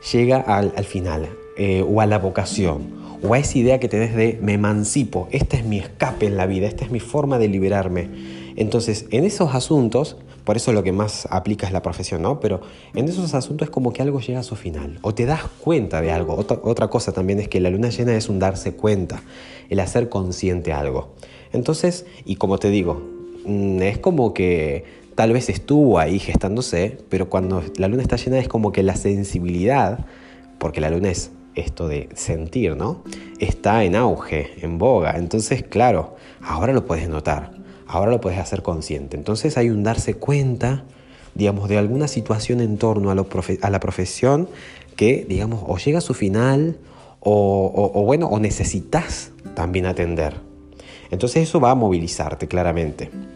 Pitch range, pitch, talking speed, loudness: 90-120 Hz, 100 Hz, 190 wpm, -20 LUFS